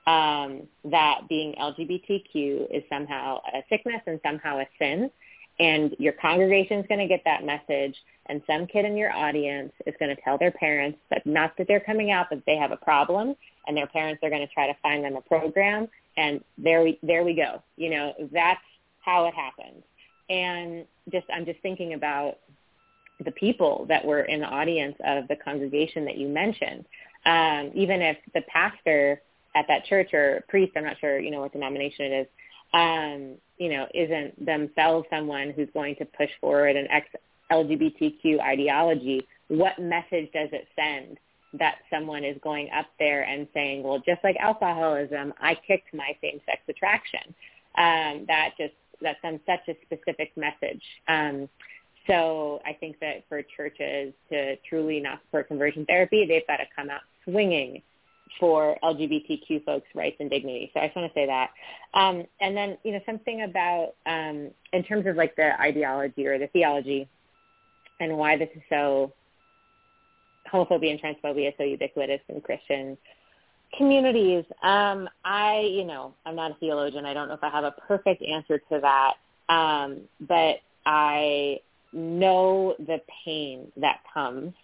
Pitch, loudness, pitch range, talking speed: 155 Hz, -26 LUFS, 145-180 Hz, 170 wpm